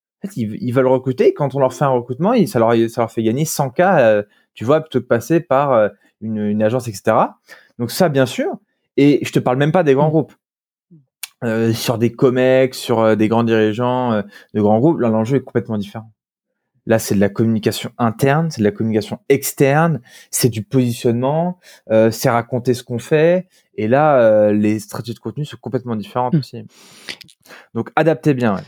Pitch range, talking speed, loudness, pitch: 110-140 Hz, 195 wpm, -17 LUFS, 125 Hz